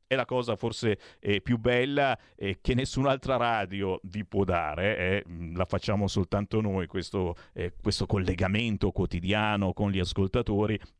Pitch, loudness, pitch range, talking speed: 100 Hz, -29 LUFS, 95-110 Hz, 145 wpm